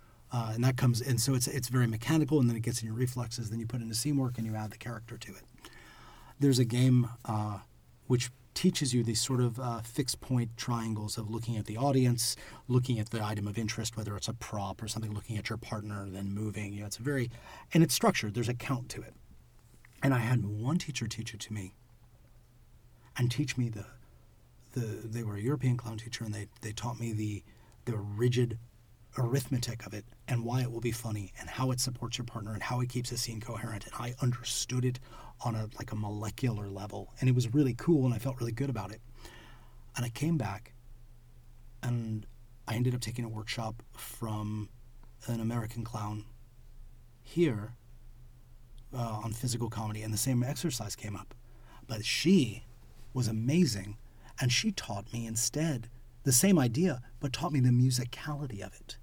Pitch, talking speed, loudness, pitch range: 120 Hz, 200 wpm, -32 LUFS, 110-125 Hz